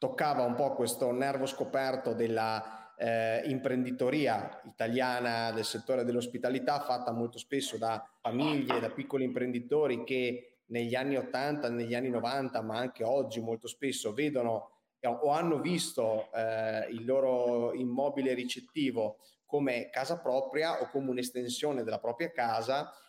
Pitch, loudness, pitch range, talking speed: 125 Hz, -33 LUFS, 115-135 Hz, 135 wpm